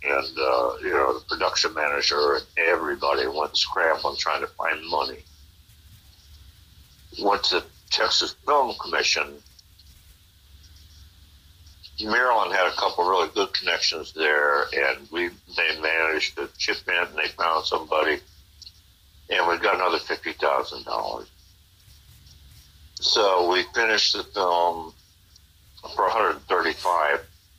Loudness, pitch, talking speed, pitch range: -23 LUFS, 85 Hz, 125 wpm, 80-95 Hz